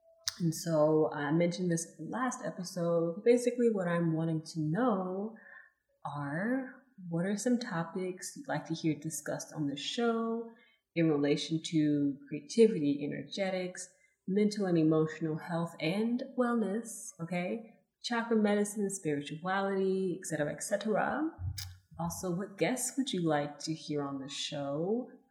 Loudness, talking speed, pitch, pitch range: -33 LUFS, 135 wpm, 175 Hz, 155-215 Hz